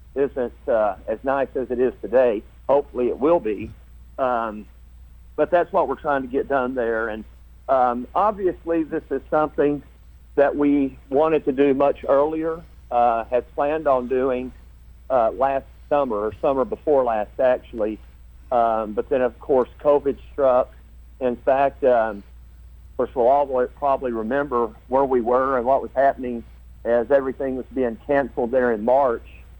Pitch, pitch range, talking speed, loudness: 125 Hz, 105-140 Hz, 160 wpm, -22 LUFS